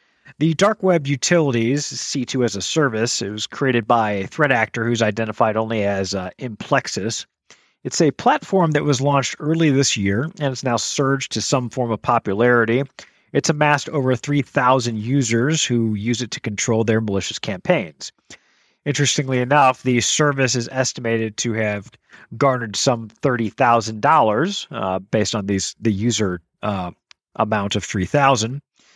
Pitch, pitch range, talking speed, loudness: 120 Hz, 110-140 Hz, 150 wpm, -19 LUFS